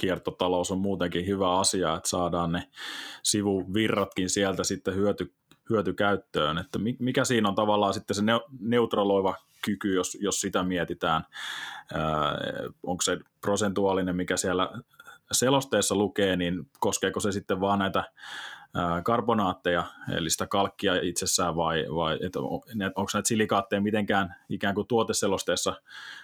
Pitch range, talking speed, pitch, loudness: 90-105 Hz, 130 wpm, 100 Hz, -27 LUFS